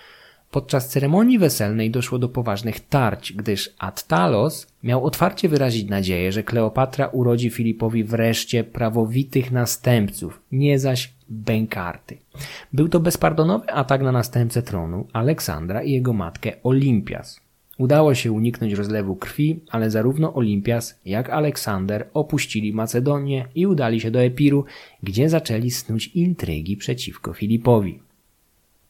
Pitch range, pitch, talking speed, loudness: 110-140 Hz, 120 Hz, 120 wpm, -21 LUFS